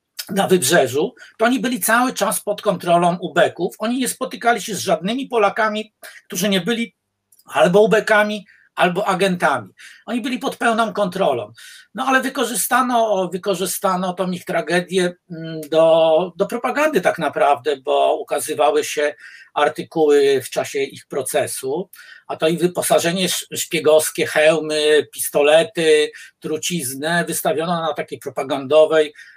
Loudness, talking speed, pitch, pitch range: -18 LUFS, 125 wpm, 195 Hz, 160-230 Hz